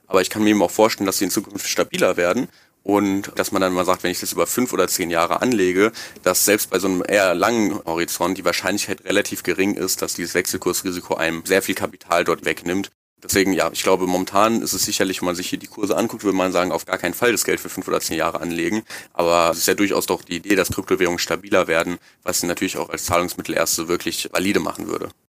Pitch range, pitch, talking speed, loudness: 85-95 Hz, 90 Hz, 245 wpm, -20 LUFS